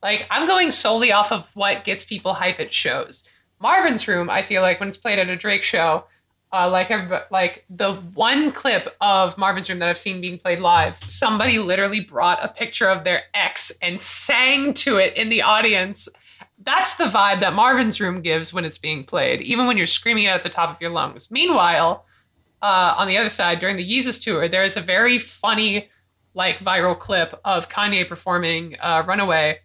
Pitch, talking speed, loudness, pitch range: 195 Hz, 200 wpm, -19 LUFS, 180-225 Hz